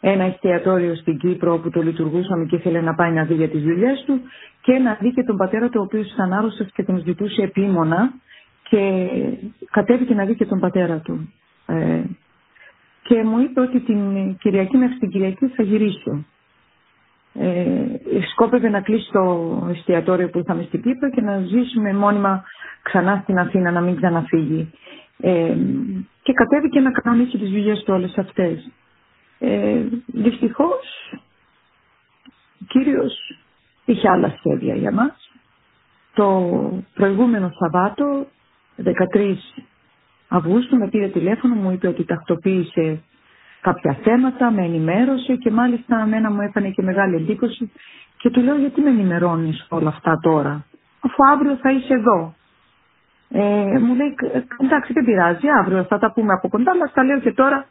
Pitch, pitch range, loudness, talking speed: 205 Hz, 180-245 Hz, -19 LUFS, 150 wpm